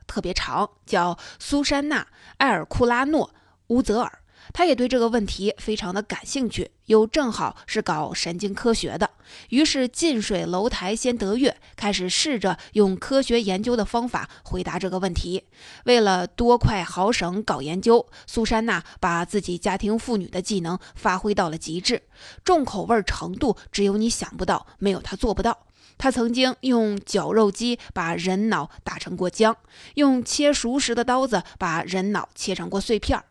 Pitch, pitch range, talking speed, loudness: 215 Hz, 190-240 Hz, 250 characters per minute, -23 LUFS